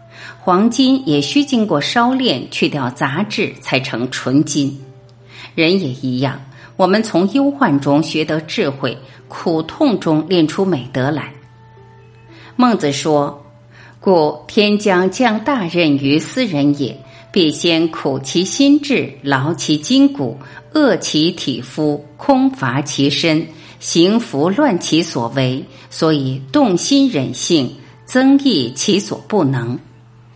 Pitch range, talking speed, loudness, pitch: 135-200 Hz, 170 characters per minute, -15 LUFS, 150 Hz